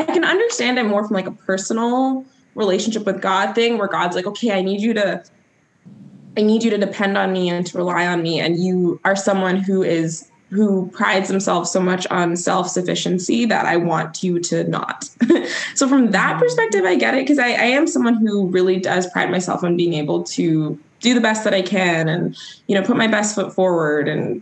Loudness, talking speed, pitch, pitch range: -18 LUFS, 215 wpm, 195 Hz, 175-225 Hz